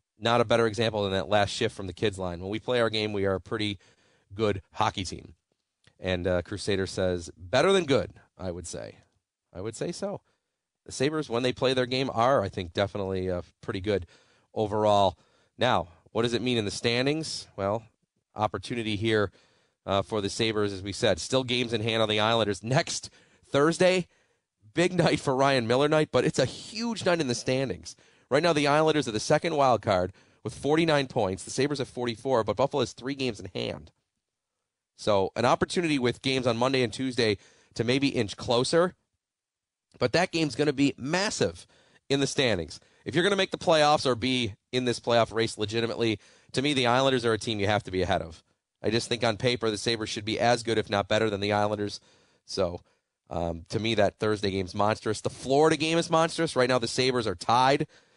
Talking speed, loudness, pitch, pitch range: 210 wpm, -27 LUFS, 115 Hz, 105-135 Hz